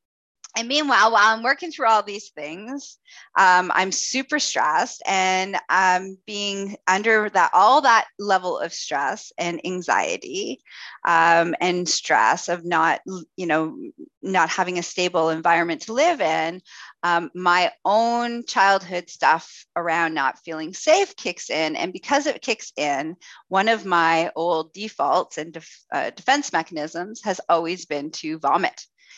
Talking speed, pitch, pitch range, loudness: 145 wpm, 180 Hz, 165-220 Hz, -21 LUFS